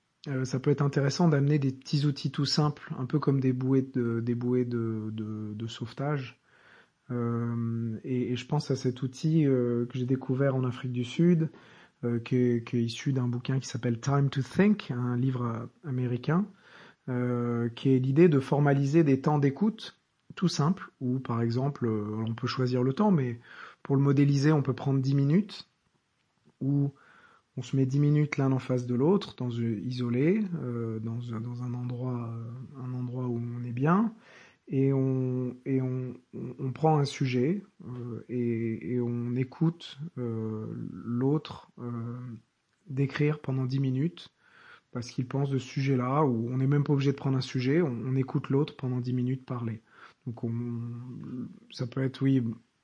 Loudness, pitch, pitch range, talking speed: -29 LUFS, 130 Hz, 120-145 Hz, 175 wpm